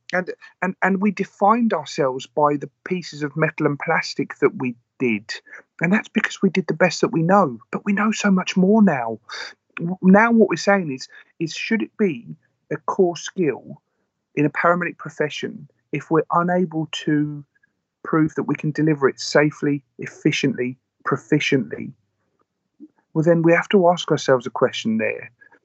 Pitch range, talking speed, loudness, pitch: 150-200 Hz, 170 wpm, -20 LUFS, 165 Hz